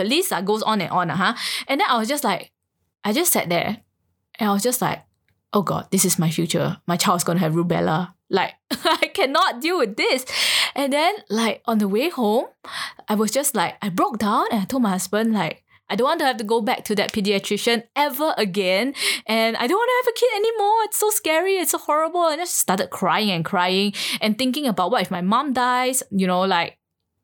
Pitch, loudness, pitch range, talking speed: 225 Hz, -21 LUFS, 190-285 Hz, 230 wpm